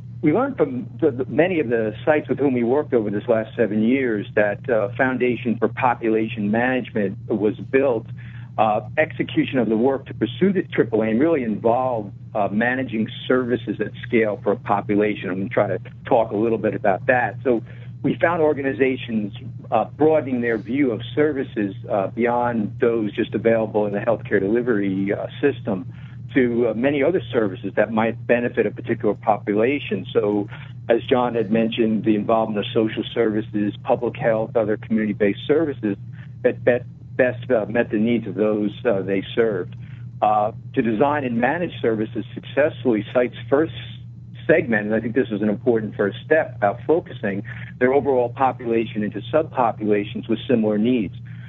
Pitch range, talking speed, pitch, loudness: 110-125 Hz, 165 wpm, 120 Hz, -21 LUFS